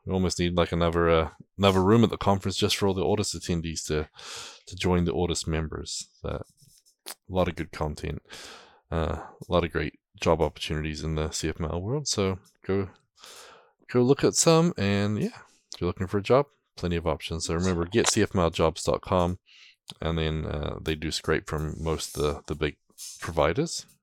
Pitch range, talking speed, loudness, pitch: 80-100 Hz, 185 wpm, -27 LUFS, 85 Hz